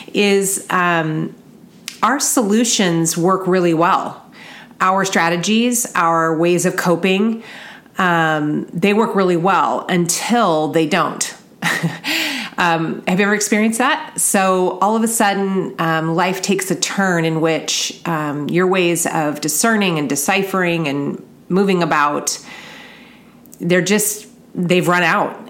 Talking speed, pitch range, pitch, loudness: 125 wpm, 170-220 Hz, 190 Hz, -16 LUFS